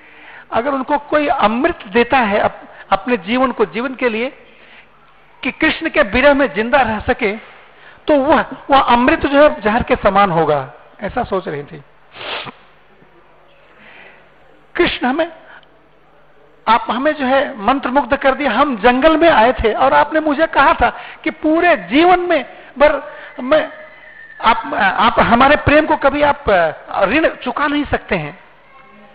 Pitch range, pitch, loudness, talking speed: 240-305 Hz, 275 Hz, -14 LUFS, 150 wpm